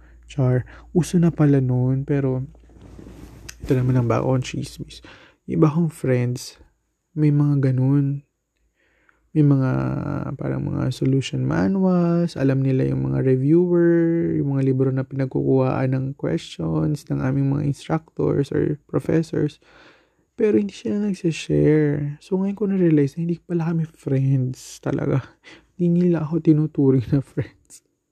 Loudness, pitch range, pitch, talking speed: -21 LUFS, 130-165 Hz, 145 Hz, 130 wpm